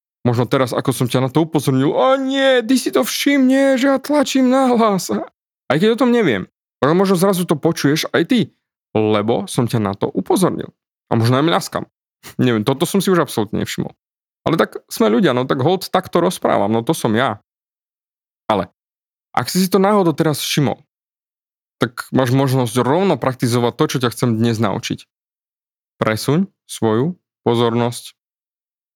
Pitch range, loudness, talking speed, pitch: 120-200 Hz, -17 LUFS, 175 wpm, 150 Hz